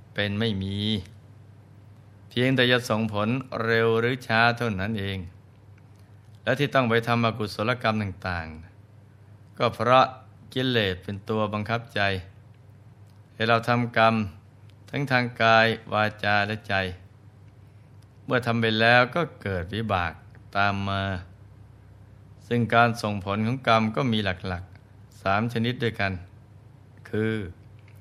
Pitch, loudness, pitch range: 110 Hz, -25 LUFS, 100-115 Hz